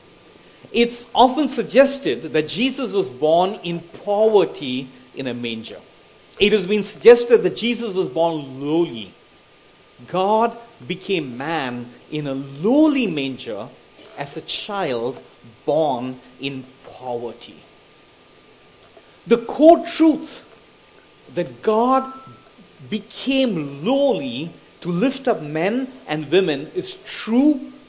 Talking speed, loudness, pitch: 105 wpm, -20 LUFS, 200 Hz